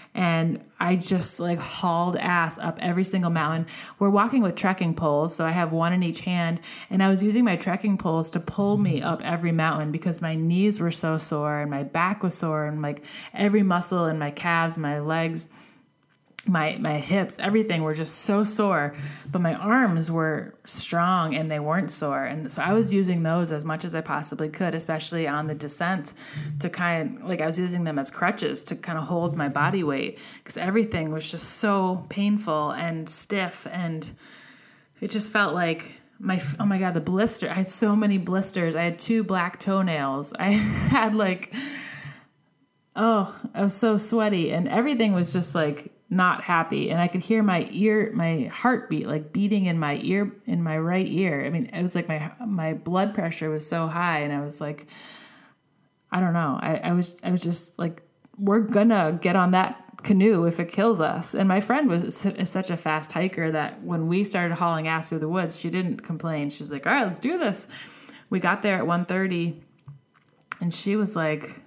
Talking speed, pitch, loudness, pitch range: 200 wpm, 175 Hz, -25 LUFS, 160-200 Hz